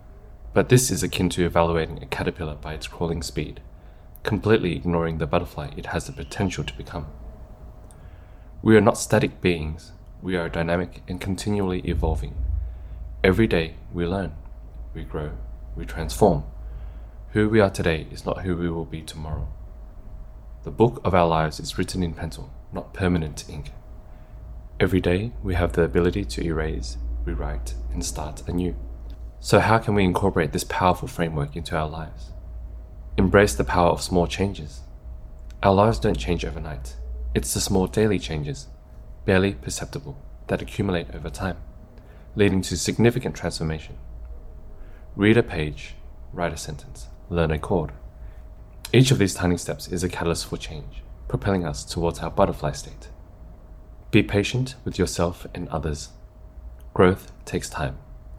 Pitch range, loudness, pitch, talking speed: 75-95 Hz, -24 LUFS, 85 Hz, 150 wpm